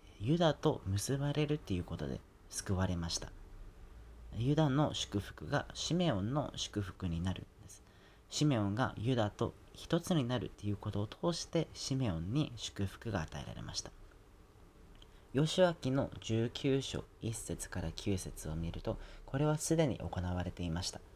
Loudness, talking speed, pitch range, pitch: -36 LUFS, 285 characters per minute, 90-135 Hz, 100 Hz